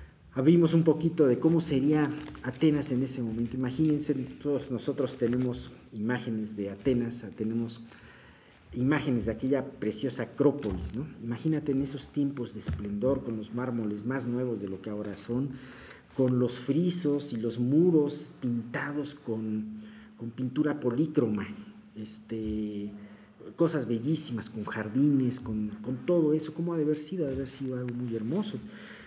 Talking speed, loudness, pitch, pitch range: 150 wpm, -29 LUFS, 130 Hz, 115-150 Hz